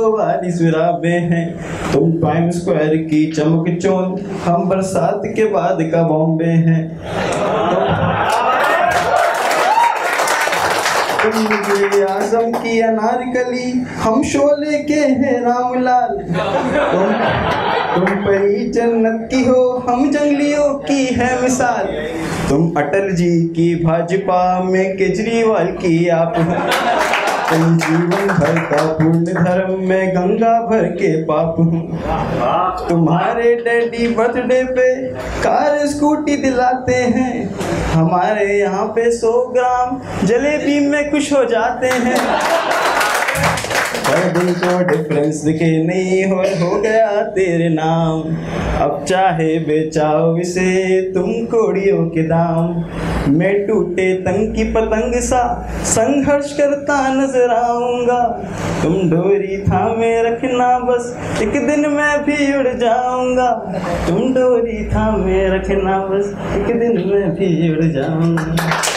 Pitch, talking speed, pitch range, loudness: 195 Hz, 105 wpm, 170-245 Hz, -15 LUFS